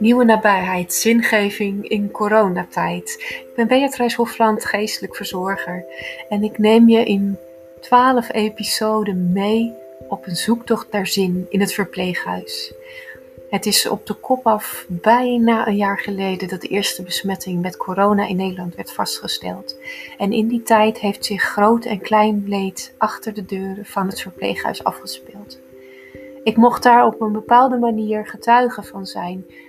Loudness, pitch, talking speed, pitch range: -18 LUFS, 210 Hz, 150 wpm, 185-225 Hz